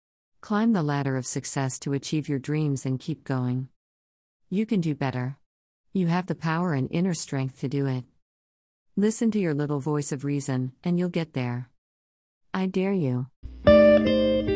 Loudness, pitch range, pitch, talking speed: -26 LUFS, 105-160 Hz, 135 Hz, 165 wpm